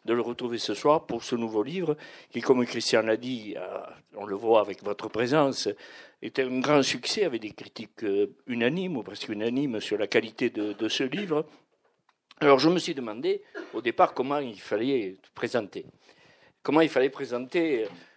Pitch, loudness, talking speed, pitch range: 135 Hz, -27 LUFS, 175 wpm, 120-165 Hz